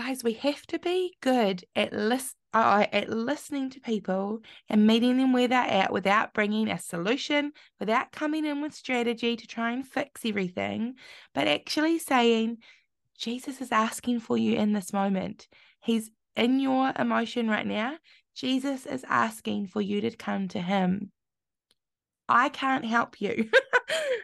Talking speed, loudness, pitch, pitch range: 155 wpm, -27 LUFS, 235 Hz, 215-265 Hz